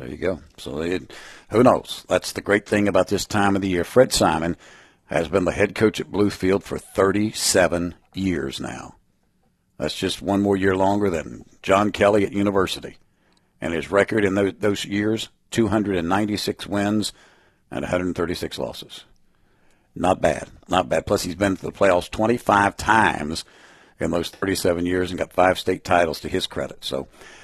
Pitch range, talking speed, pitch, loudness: 90-105 Hz, 170 wpm, 95 Hz, -22 LUFS